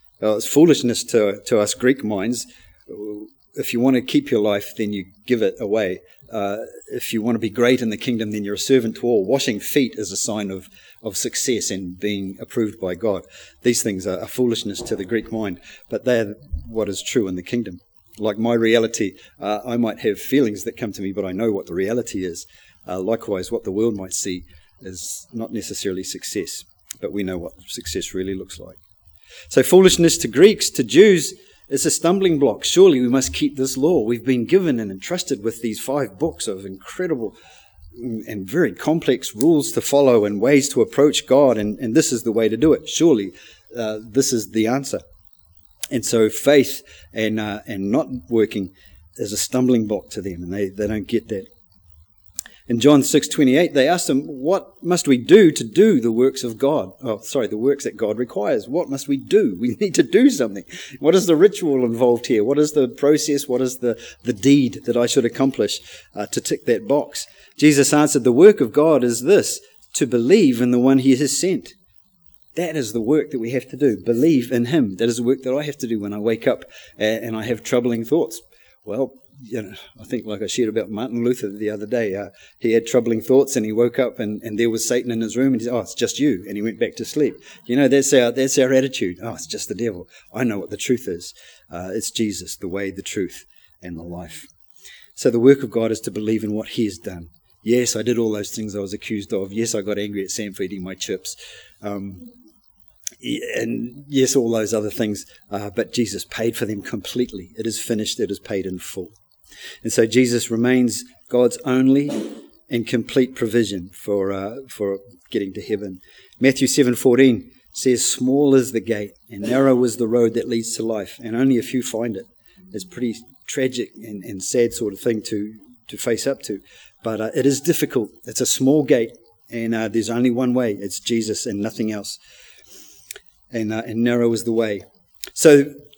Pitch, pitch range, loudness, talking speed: 115 Hz, 105-130 Hz, -20 LUFS, 215 wpm